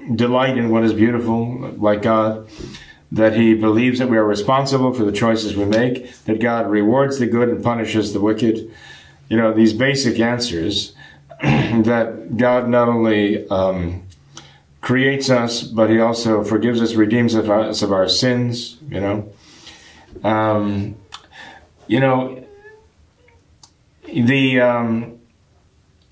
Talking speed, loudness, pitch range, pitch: 130 wpm, -17 LUFS, 105-120 Hz, 115 Hz